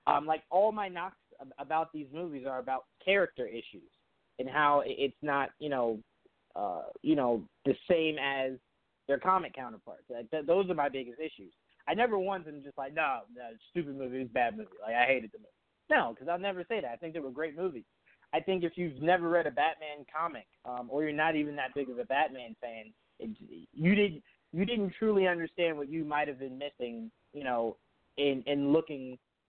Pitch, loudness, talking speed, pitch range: 145 Hz, -32 LUFS, 215 wpm, 130-175 Hz